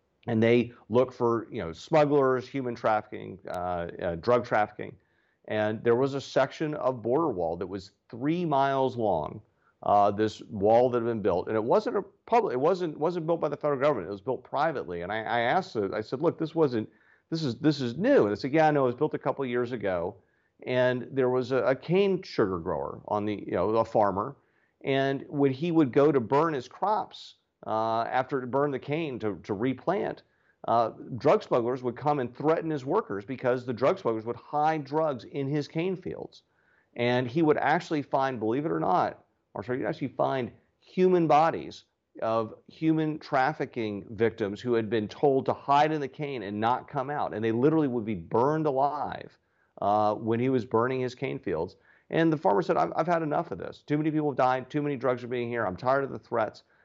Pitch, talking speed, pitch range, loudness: 130 Hz, 215 wpm, 115-150 Hz, -28 LUFS